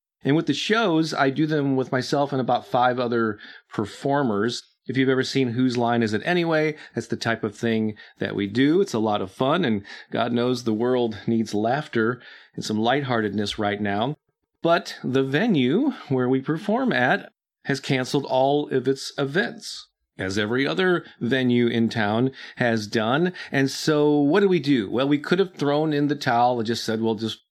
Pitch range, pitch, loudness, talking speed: 115-145 Hz, 130 Hz, -23 LUFS, 190 wpm